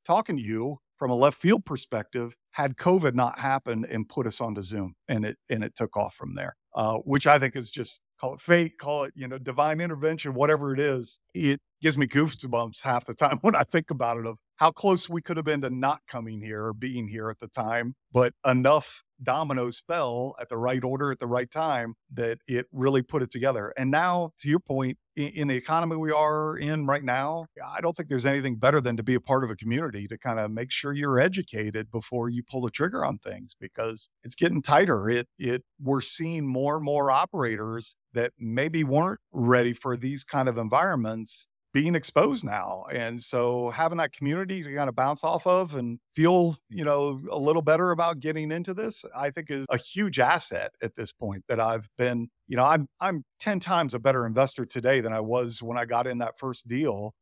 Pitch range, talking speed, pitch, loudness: 120-155 Hz, 220 wpm, 135 Hz, -27 LUFS